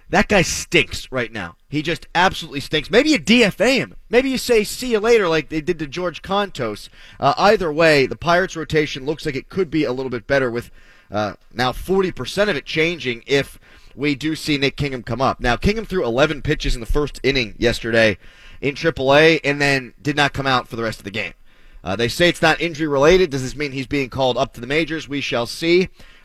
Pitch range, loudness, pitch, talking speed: 125-165 Hz, -19 LUFS, 145 Hz, 230 wpm